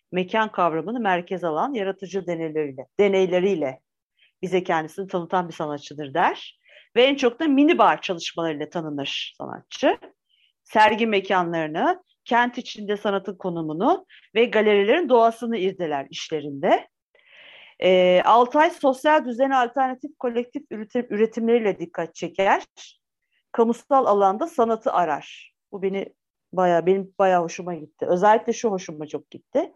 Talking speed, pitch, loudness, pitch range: 115 wpm, 195 Hz, -22 LUFS, 175-240 Hz